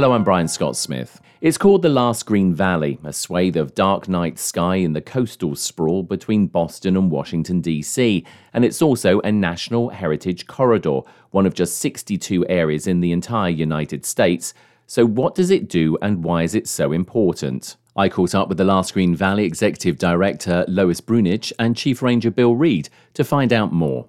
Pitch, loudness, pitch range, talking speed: 95 Hz, -19 LUFS, 85-115 Hz, 185 wpm